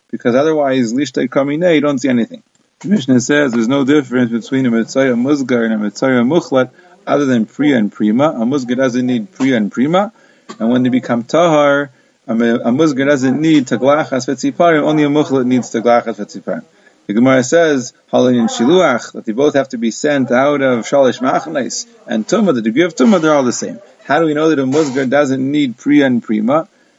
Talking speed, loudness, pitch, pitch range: 195 wpm, -14 LUFS, 140 Hz, 125-160 Hz